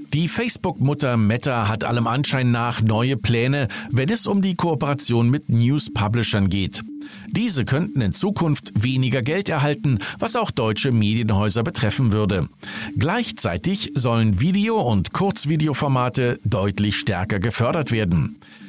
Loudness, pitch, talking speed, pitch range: -20 LUFS, 125 Hz, 125 wpm, 110-160 Hz